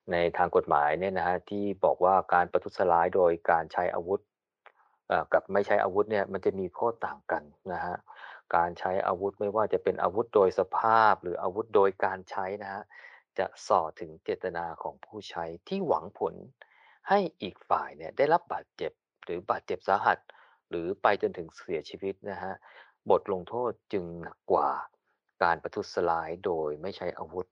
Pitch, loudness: 100 Hz, -29 LUFS